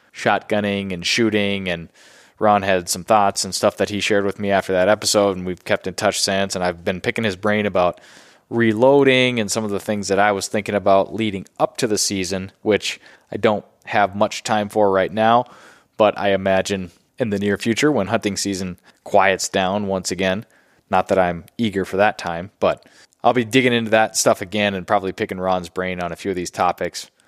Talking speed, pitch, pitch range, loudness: 210 wpm, 100 Hz, 95-110 Hz, -19 LUFS